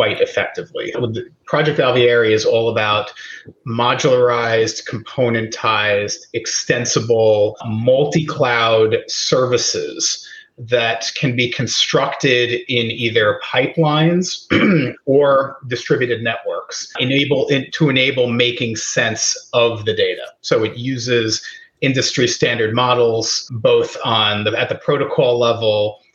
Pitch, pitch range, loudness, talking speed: 125 Hz, 115-145 Hz, -16 LUFS, 100 wpm